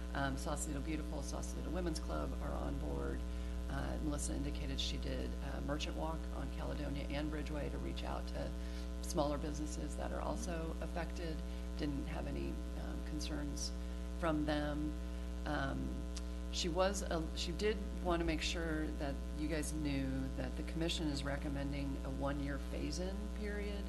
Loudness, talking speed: -41 LUFS, 155 wpm